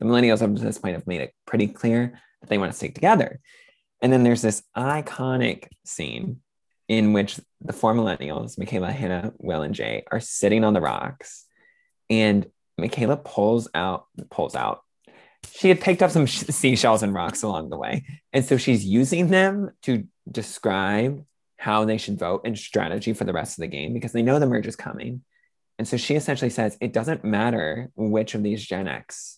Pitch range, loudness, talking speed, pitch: 110-140 Hz, -23 LUFS, 190 wpm, 120 Hz